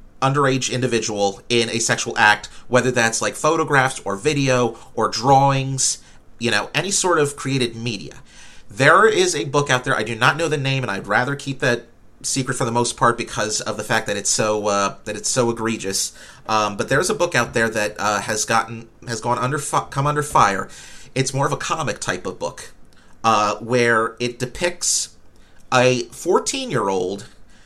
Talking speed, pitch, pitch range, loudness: 195 wpm, 120 Hz, 105-135 Hz, -19 LUFS